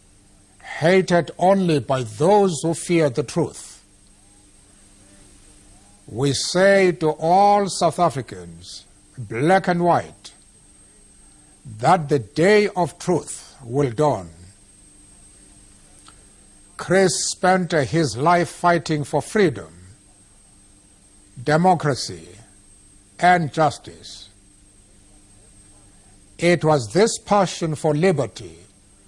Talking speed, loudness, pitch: 85 wpm, -19 LUFS, 120 Hz